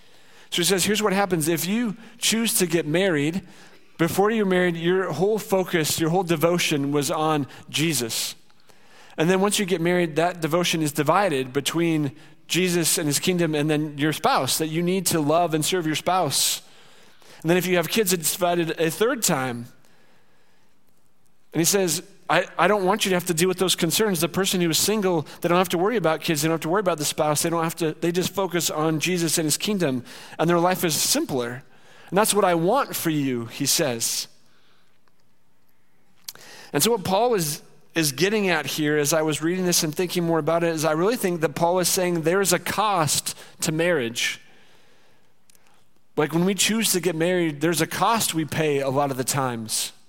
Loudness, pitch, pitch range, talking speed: -22 LUFS, 170 Hz, 155-185 Hz, 210 wpm